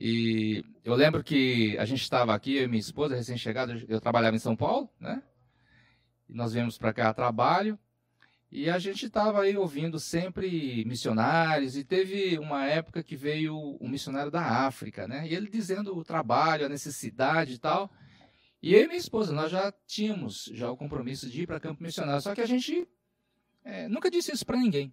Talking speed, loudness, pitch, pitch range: 195 wpm, -29 LUFS, 145 Hz, 120-185 Hz